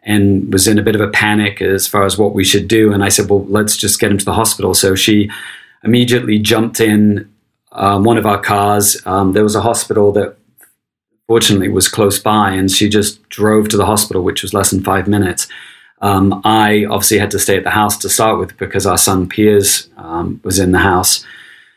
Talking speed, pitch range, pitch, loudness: 220 wpm, 100-105 Hz, 105 Hz, -12 LUFS